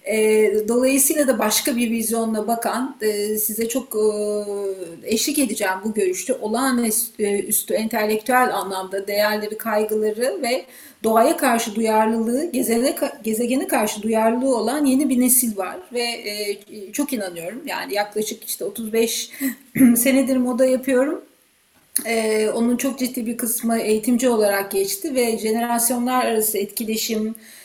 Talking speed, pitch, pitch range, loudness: 115 wpm, 230 Hz, 215-255 Hz, -20 LUFS